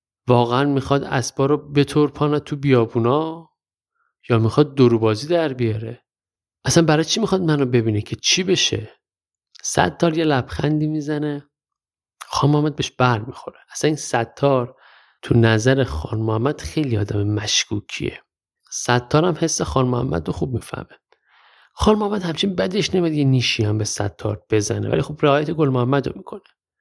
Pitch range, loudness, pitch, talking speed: 115-150 Hz, -20 LUFS, 135 Hz, 155 wpm